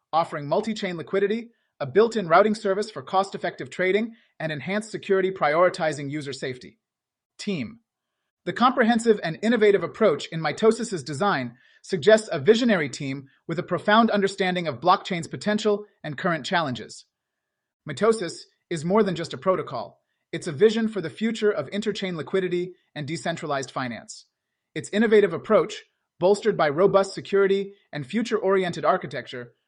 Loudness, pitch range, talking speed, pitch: -24 LUFS, 165-210 Hz, 135 wpm, 190 Hz